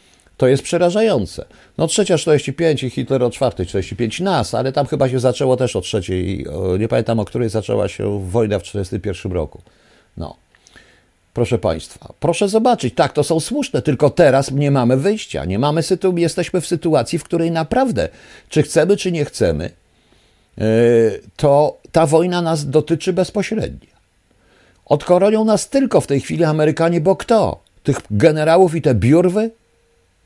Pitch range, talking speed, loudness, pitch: 115-170 Hz, 150 wpm, -17 LUFS, 145 Hz